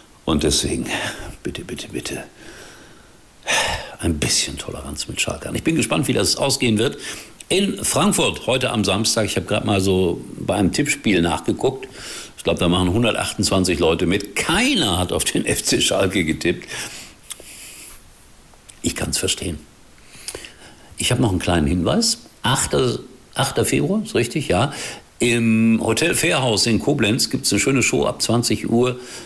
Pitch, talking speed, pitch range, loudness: 115 Hz, 150 wpm, 100-125 Hz, -19 LUFS